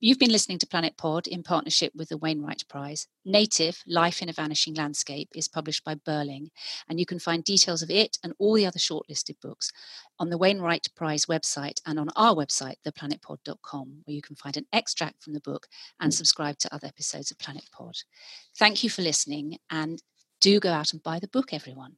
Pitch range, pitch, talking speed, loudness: 150-175 Hz, 160 Hz, 205 wpm, -26 LUFS